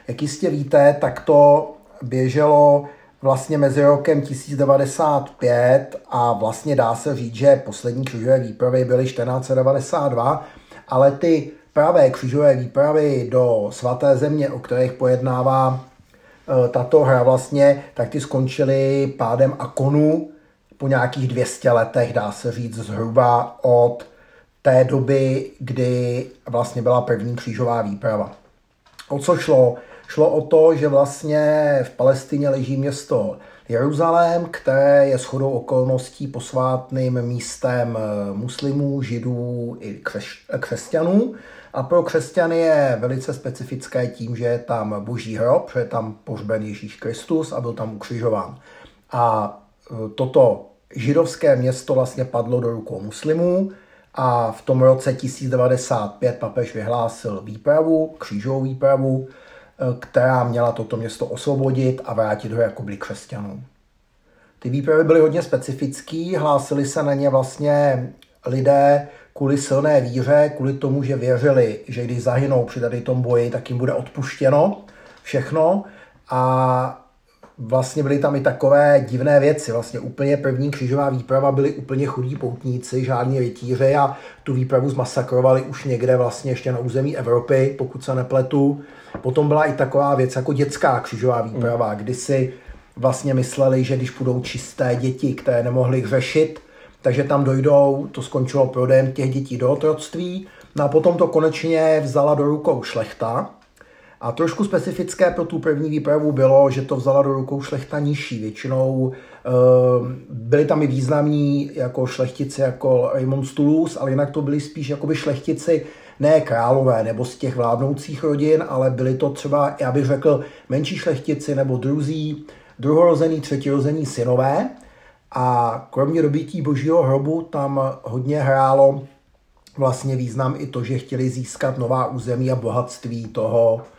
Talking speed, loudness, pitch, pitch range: 140 wpm, -19 LUFS, 135 Hz, 125-145 Hz